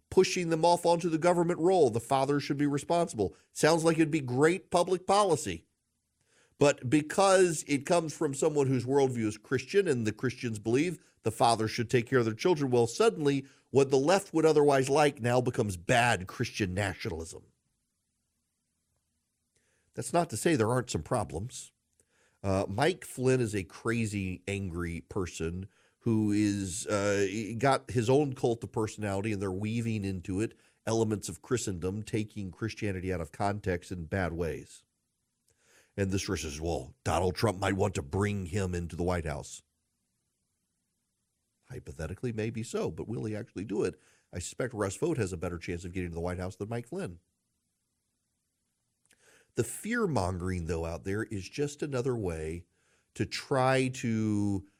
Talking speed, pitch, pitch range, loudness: 165 wpm, 110 Hz, 95-140 Hz, -30 LUFS